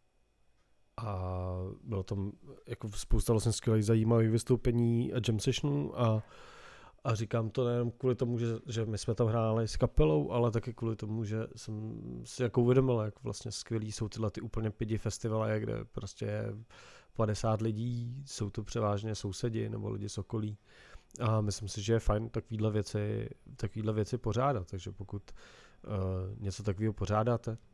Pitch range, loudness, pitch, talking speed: 105-115 Hz, -34 LUFS, 110 Hz, 160 wpm